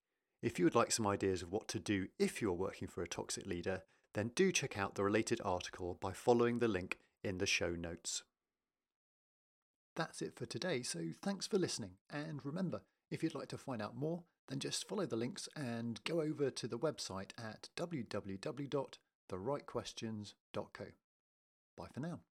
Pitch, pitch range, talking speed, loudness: 120 Hz, 100-155 Hz, 175 wpm, -40 LUFS